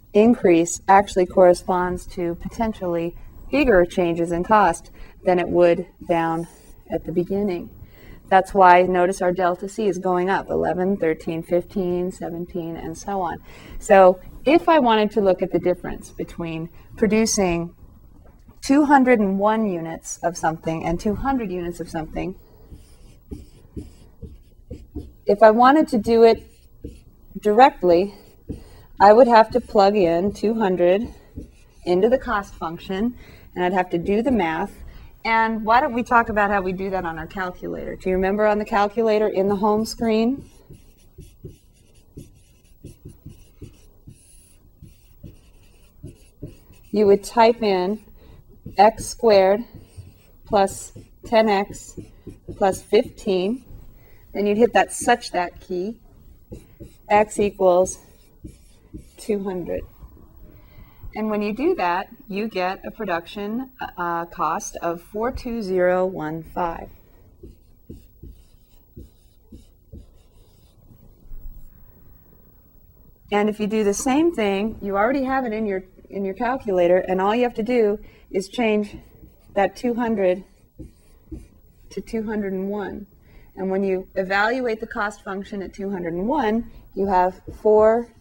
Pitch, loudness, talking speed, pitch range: 190 Hz, -20 LUFS, 120 wpm, 170-215 Hz